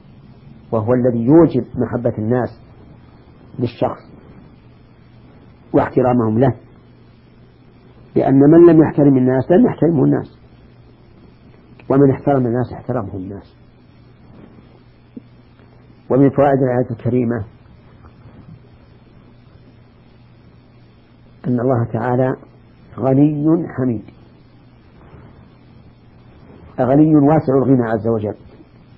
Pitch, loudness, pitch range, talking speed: 125 Hz, -15 LUFS, 120-135 Hz, 70 wpm